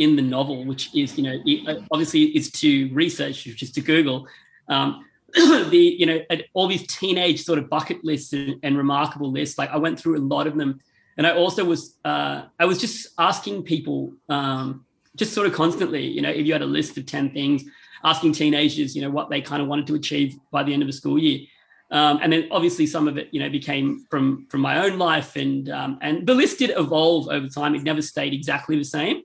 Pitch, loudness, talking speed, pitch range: 150 Hz, -22 LUFS, 230 wpm, 140-165 Hz